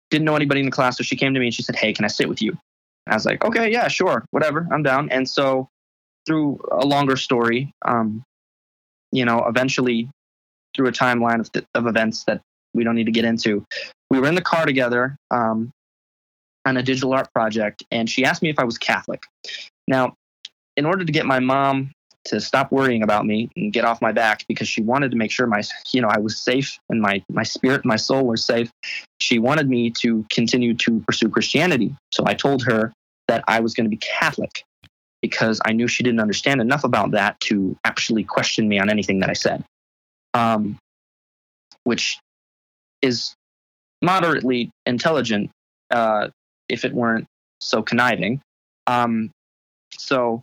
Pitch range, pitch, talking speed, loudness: 110-130 Hz, 120 Hz, 195 wpm, -20 LUFS